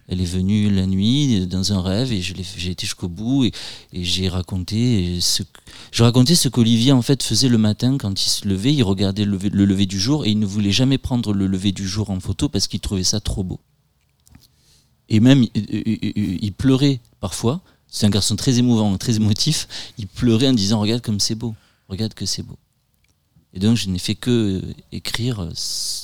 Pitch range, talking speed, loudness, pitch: 95-120 Hz, 205 wpm, -19 LUFS, 105 Hz